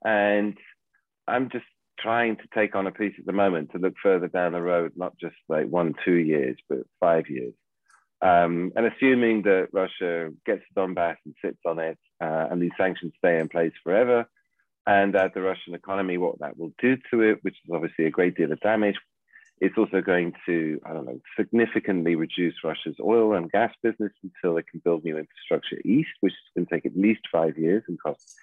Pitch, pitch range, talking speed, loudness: 95 Hz, 85-105 Hz, 205 wpm, -25 LUFS